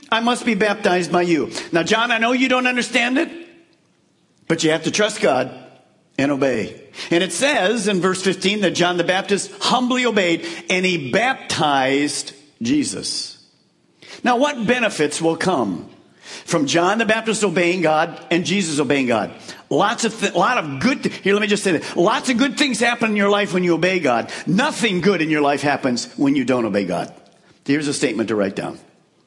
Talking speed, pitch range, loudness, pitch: 195 wpm, 165-235 Hz, -19 LUFS, 195 Hz